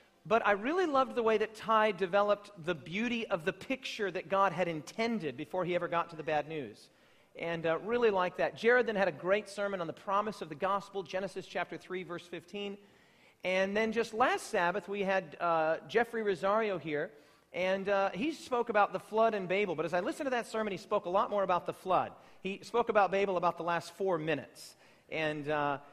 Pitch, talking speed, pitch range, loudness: 195 Hz, 220 wpm, 175-215 Hz, -33 LUFS